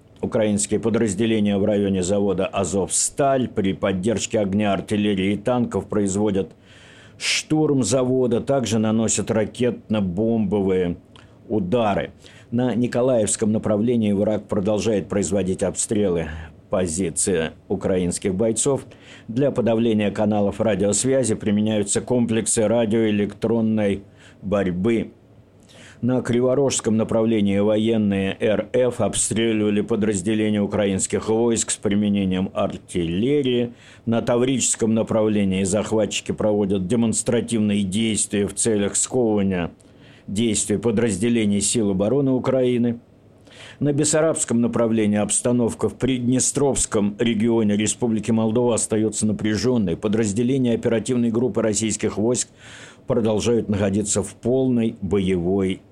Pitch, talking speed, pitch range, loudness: 110 Hz, 90 wpm, 100-120 Hz, -21 LUFS